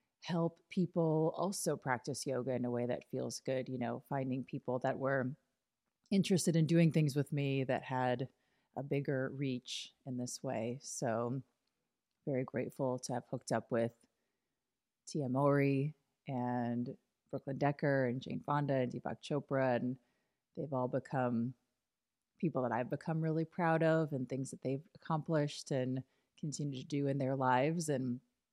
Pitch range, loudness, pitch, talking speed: 125-145 Hz, -37 LUFS, 135 Hz, 155 wpm